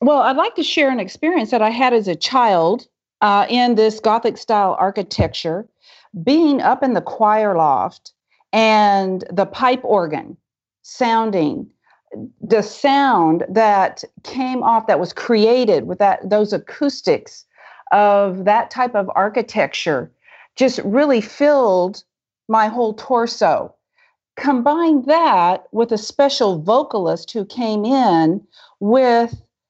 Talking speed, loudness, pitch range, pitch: 125 wpm, -17 LUFS, 205-260 Hz, 225 Hz